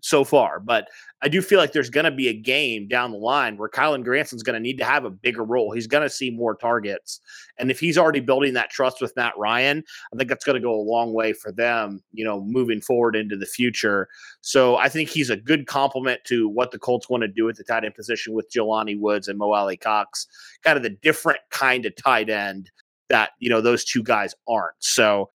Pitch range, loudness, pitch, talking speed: 110-135 Hz, -22 LUFS, 120 Hz, 245 wpm